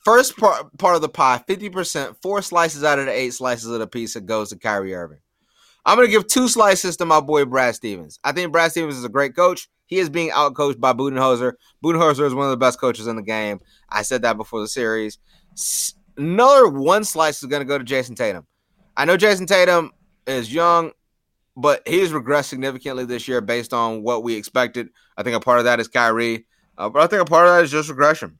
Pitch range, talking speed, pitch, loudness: 120-175 Hz, 230 wpm, 140 Hz, -18 LUFS